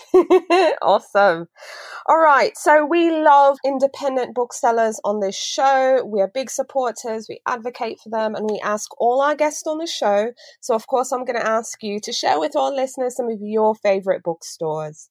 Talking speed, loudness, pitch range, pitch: 185 wpm, -19 LUFS, 215-275 Hz, 245 Hz